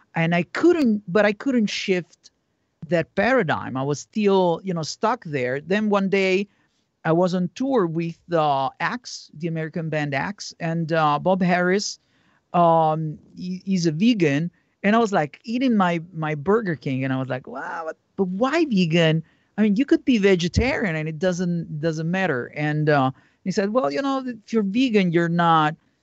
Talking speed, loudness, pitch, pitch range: 185 wpm, -22 LUFS, 175 Hz, 160-205 Hz